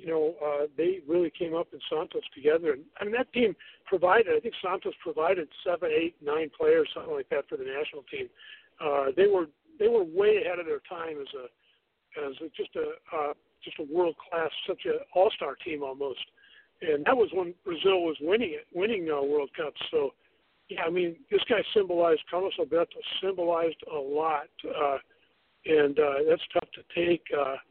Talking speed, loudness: 190 wpm, -29 LUFS